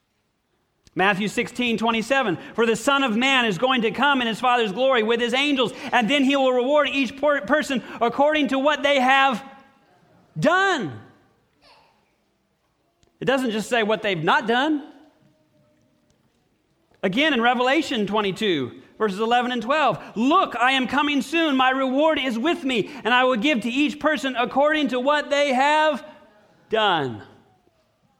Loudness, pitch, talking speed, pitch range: -21 LUFS, 260 Hz, 150 wpm, 230-285 Hz